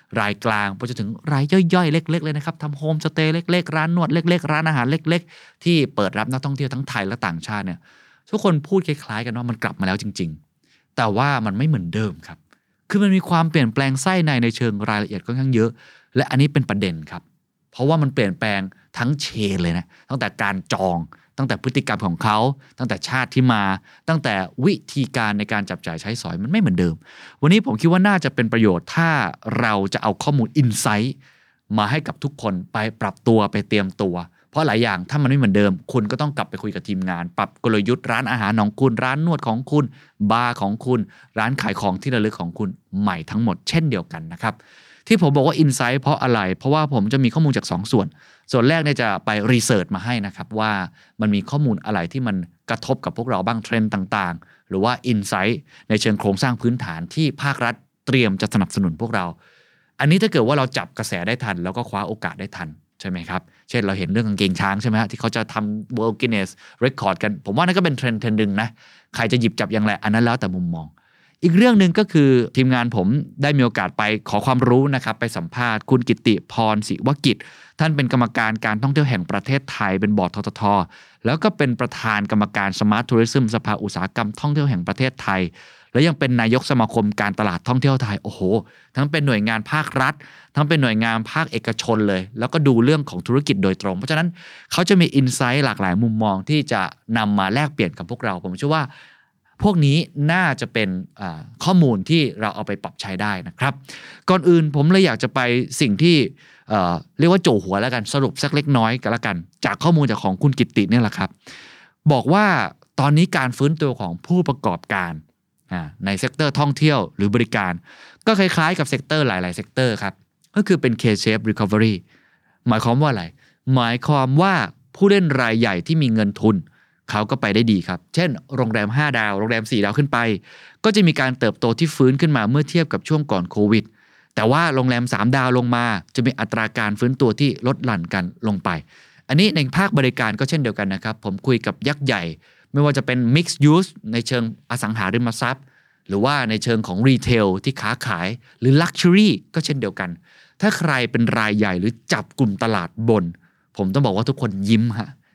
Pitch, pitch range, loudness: 120 Hz, 105-145 Hz, -20 LUFS